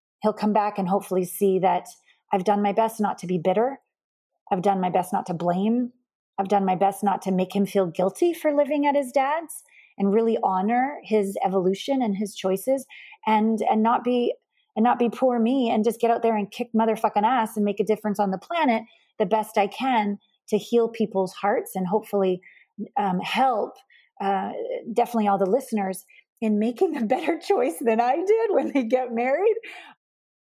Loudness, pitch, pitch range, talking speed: -24 LUFS, 220 Hz, 200-255 Hz, 195 wpm